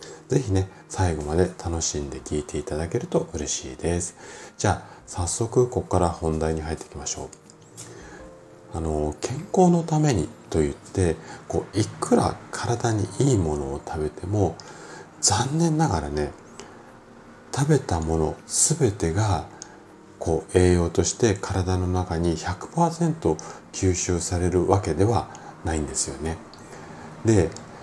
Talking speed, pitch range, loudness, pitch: 255 characters per minute, 80-110 Hz, -24 LUFS, 90 Hz